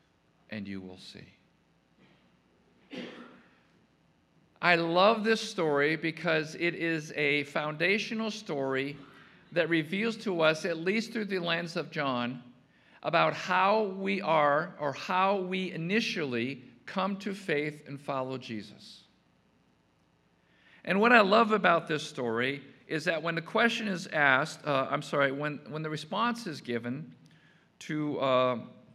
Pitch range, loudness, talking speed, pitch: 135-190 Hz, -29 LUFS, 135 wpm, 155 Hz